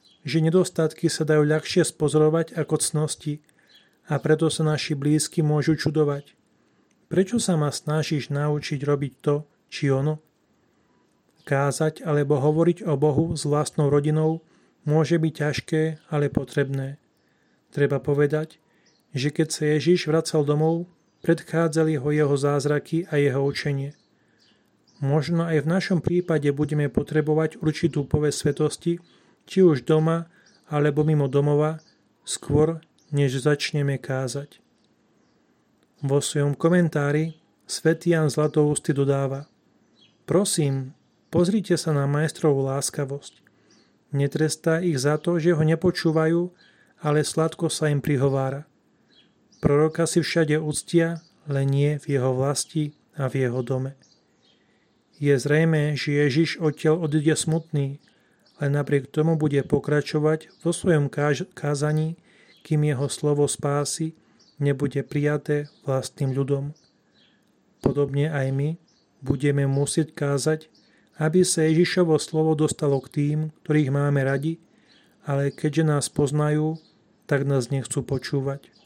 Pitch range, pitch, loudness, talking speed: 145-160 Hz, 150 Hz, -23 LUFS, 120 wpm